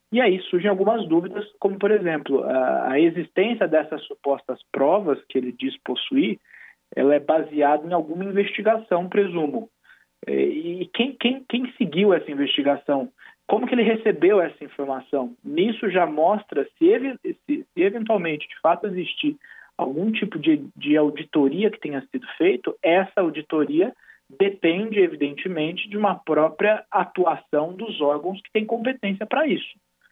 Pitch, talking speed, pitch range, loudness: 195 Hz, 145 wpm, 155-225 Hz, -22 LUFS